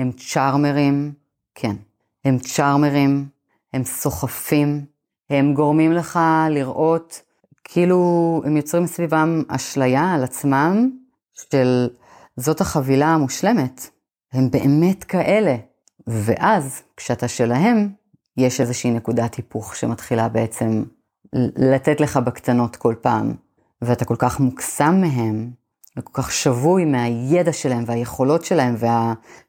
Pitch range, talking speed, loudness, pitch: 125-160 Hz, 105 wpm, -19 LUFS, 140 Hz